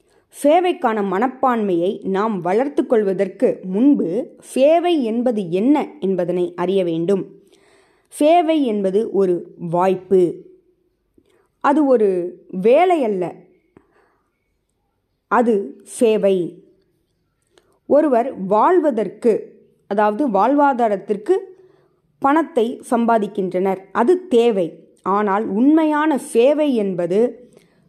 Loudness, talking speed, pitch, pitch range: -18 LUFS, 70 wpm, 230 Hz, 190-295 Hz